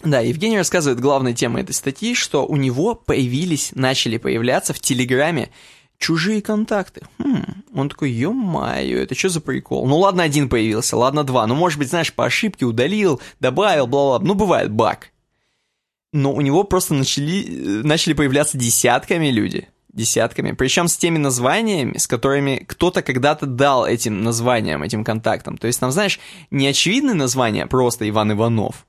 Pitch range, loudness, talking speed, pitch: 125-175 Hz, -18 LUFS, 160 wpm, 140 Hz